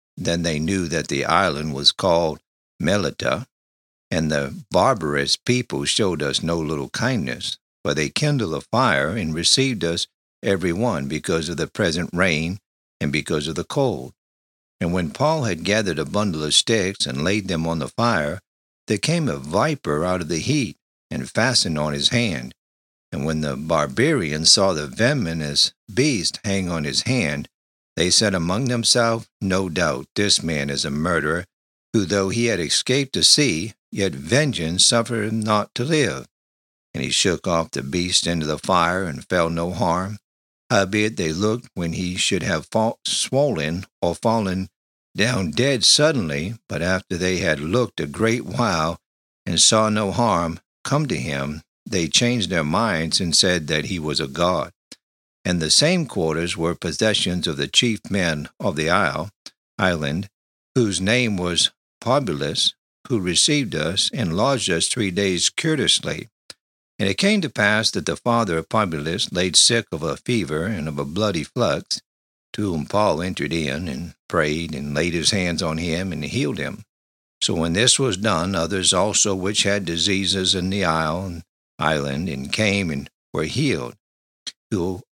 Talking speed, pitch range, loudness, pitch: 170 wpm, 75-105 Hz, -20 LUFS, 90 Hz